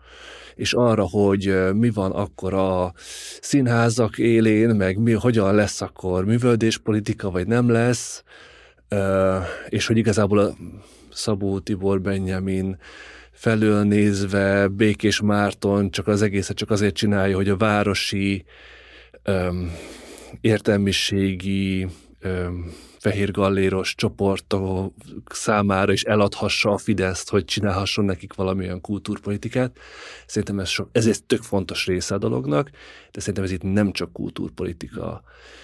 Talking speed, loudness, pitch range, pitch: 125 wpm, -22 LUFS, 95-110 Hz, 100 Hz